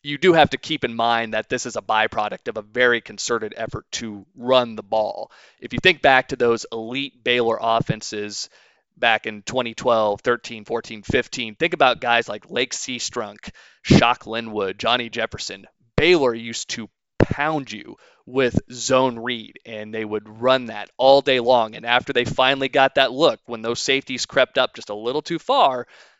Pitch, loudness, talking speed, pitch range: 120 Hz, -21 LUFS, 180 wpm, 110-130 Hz